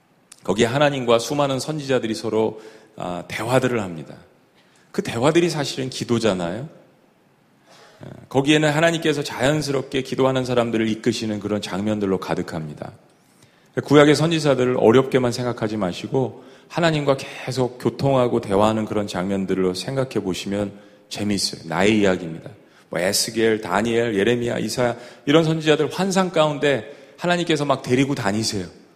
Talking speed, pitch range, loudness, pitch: 350 characters per minute, 105-140 Hz, -21 LUFS, 120 Hz